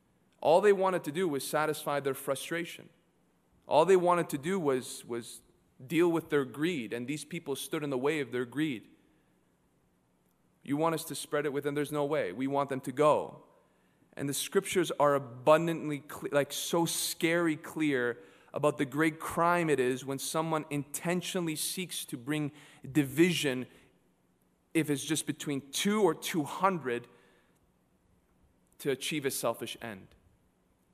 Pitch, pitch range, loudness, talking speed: 150 Hz, 135-165 Hz, -31 LUFS, 160 wpm